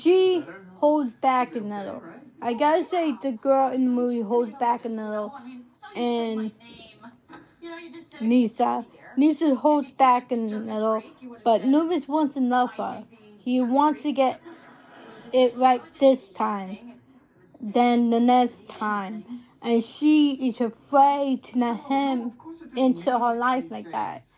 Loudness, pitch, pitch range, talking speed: -23 LUFS, 250 Hz, 235-275 Hz, 135 wpm